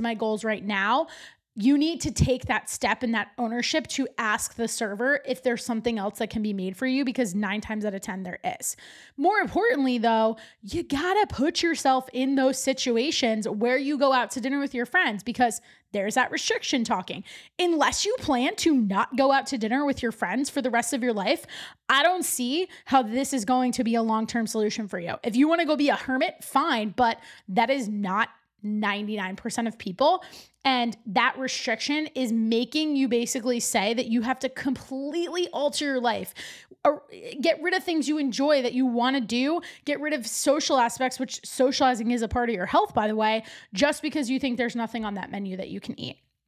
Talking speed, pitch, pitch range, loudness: 215 wpm, 255 Hz, 225-285 Hz, -25 LUFS